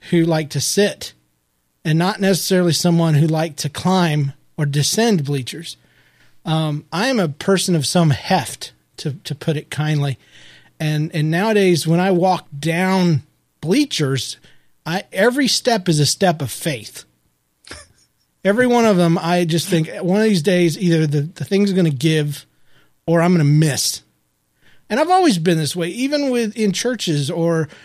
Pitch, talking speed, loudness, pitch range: 165 Hz, 170 wpm, -18 LUFS, 145-185 Hz